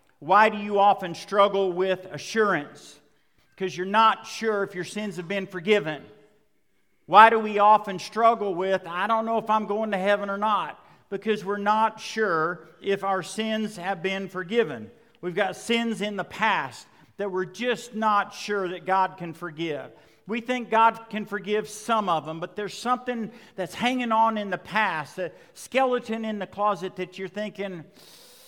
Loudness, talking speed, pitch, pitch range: -25 LUFS, 175 wpm, 205 Hz, 185-220 Hz